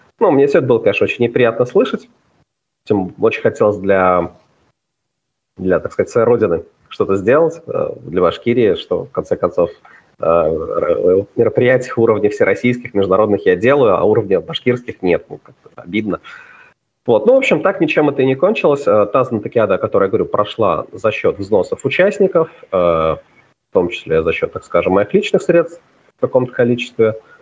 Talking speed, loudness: 160 wpm, -15 LUFS